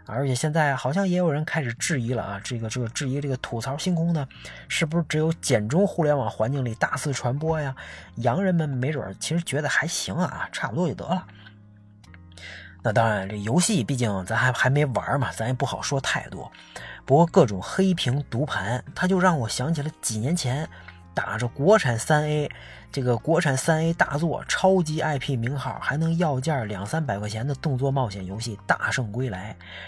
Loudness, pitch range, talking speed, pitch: -25 LUFS, 115-155 Hz, 290 characters per minute, 135 Hz